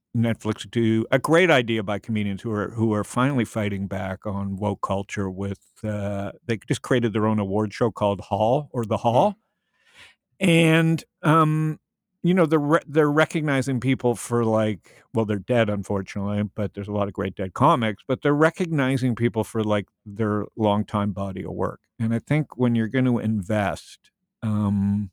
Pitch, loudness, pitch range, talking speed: 110 Hz, -23 LUFS, 105-130 Hz, 175 wpm